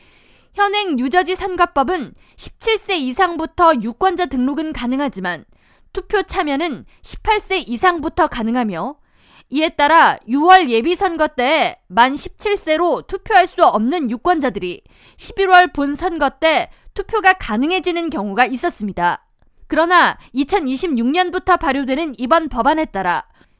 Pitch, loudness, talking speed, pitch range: 325 Hz, -16 LUFS, 255 characters per minute, 265-365 Hz